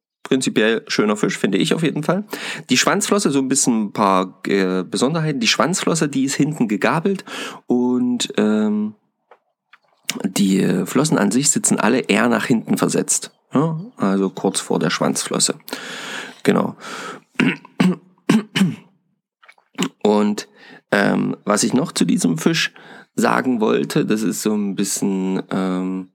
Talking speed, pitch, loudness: 130 wpm, 135 Hz, -19 LUFS